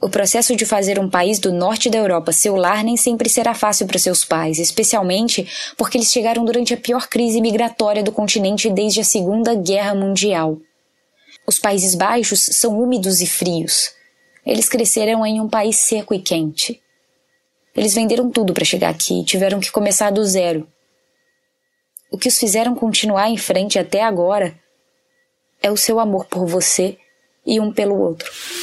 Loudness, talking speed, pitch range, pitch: -16 LUFS, 170 wpm, 190-230 Hz, 210 Hz